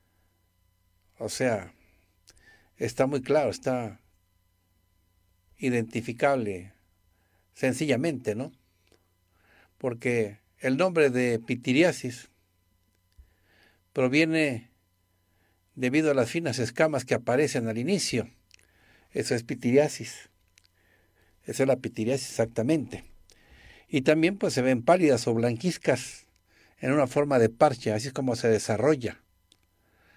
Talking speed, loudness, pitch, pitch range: 100 wpm, -27 LUFS, 110 Hz, 90-130 Hz